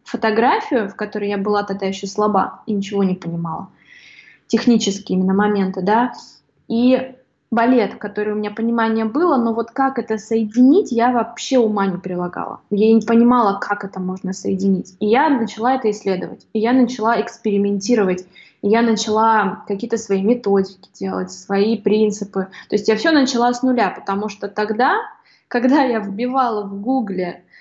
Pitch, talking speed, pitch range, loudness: 215 Hz, 160 wpm, 200-235 Hz, -18 LUFS